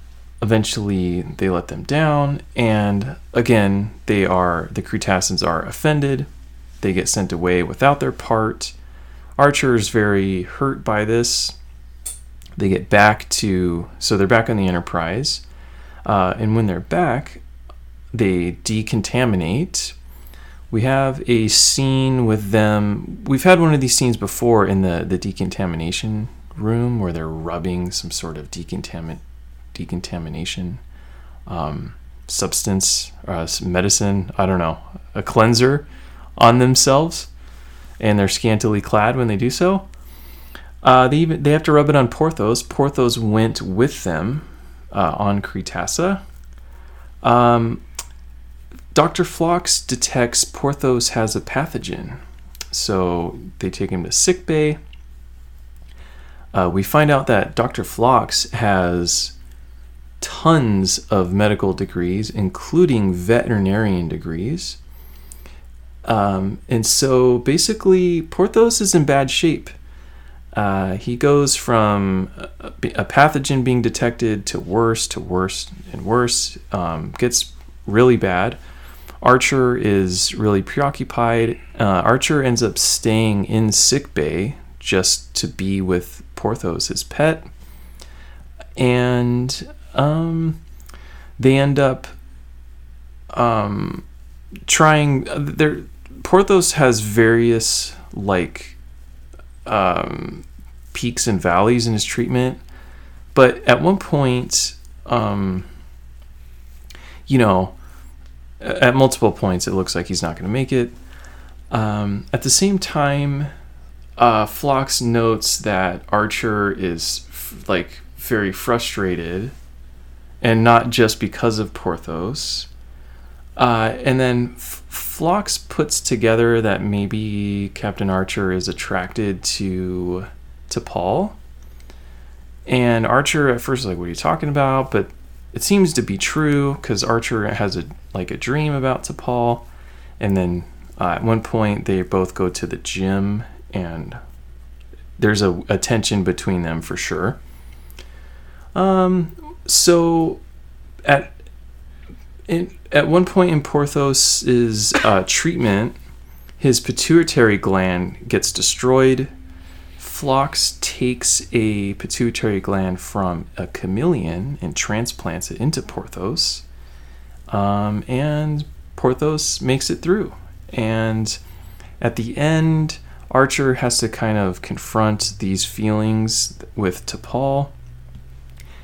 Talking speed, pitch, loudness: 120 wpm, 100 Hz, -18 LUFS